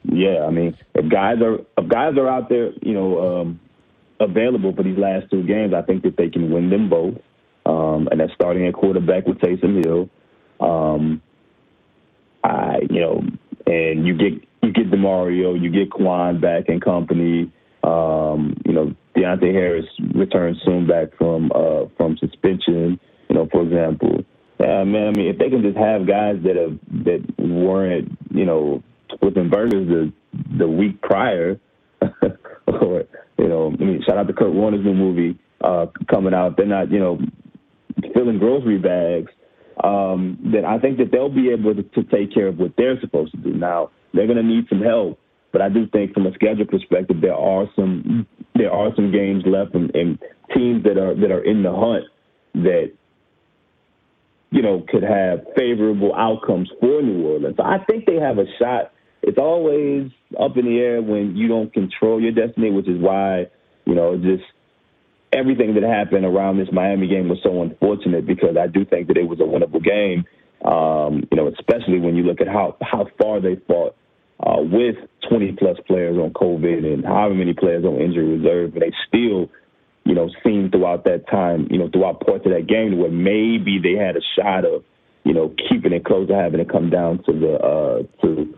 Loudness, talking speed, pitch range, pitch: -19 LUFS, 190 wpm, 85-105 Hz, 95 Hz